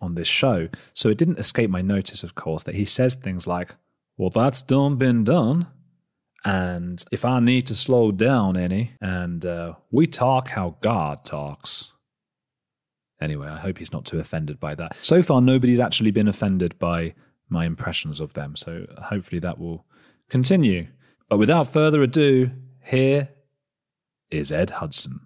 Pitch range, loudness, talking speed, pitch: 85-130 Hz, -22 LUFS, 165 wpm, 105 Hz